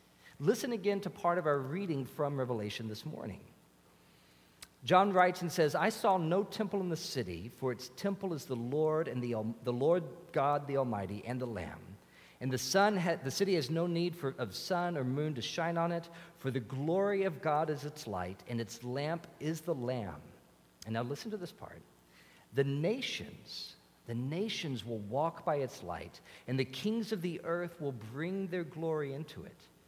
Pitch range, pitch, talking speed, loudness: 120-175 Hz, 150 Hz, 195 wpm, -35 LUFS